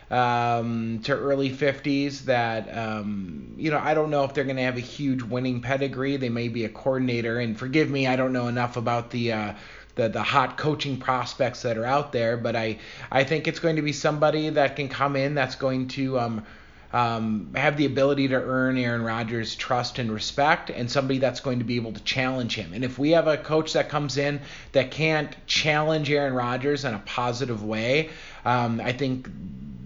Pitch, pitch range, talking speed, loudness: 130 Hz, 115-140 Hz, 205 wpm, -25 LUFS